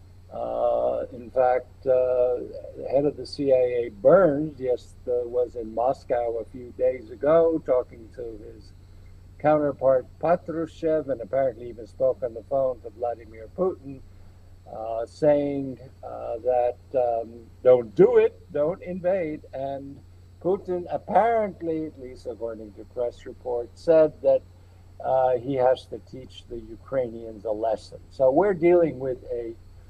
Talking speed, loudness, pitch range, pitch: 140 wpm, -25 LUFS, 110-150 Hz, 125 Hz